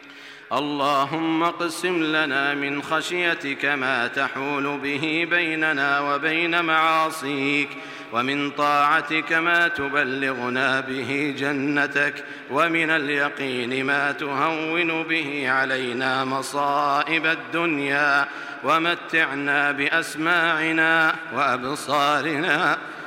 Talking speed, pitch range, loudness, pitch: 75 wpm, 140-160 Hz, -22 LUFS, 145 Hz